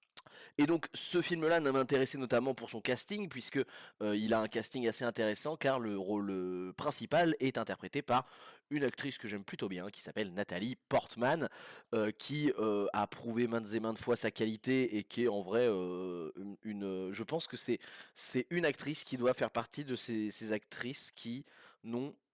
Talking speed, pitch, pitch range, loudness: 190 wpm, 120 Hz, 110-135 Hz, -36 LUFS